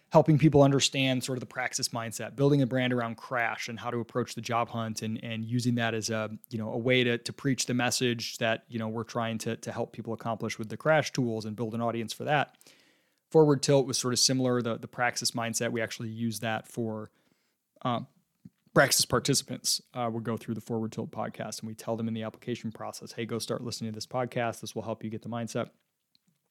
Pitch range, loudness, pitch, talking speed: 115-125 Hz, -29 LUFS, 115 Hz, 235 wpm